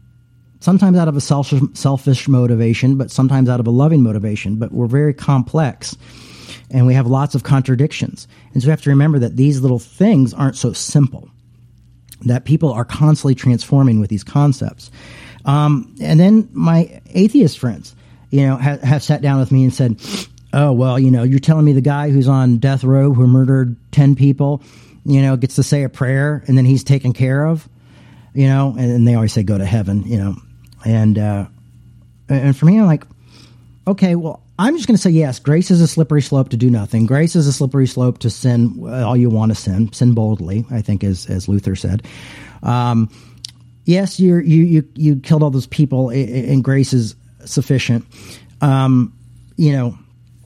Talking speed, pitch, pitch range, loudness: 195 wpm, 130 Hz, 120-145 Hz, -15 LUFS